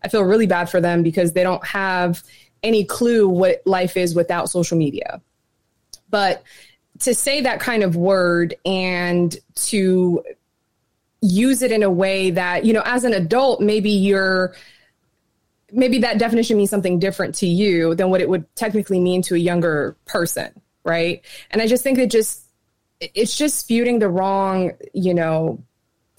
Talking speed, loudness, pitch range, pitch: 165 wpm, -18 LUFS, 175-220 Hz, 190 Hz